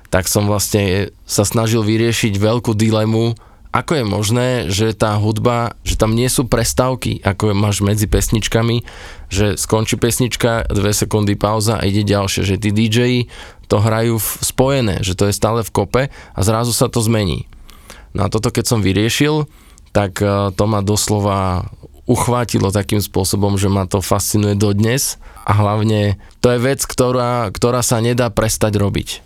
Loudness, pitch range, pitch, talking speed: -16 LUFS, 100-120 Hz, 110 Hz, 165 wpm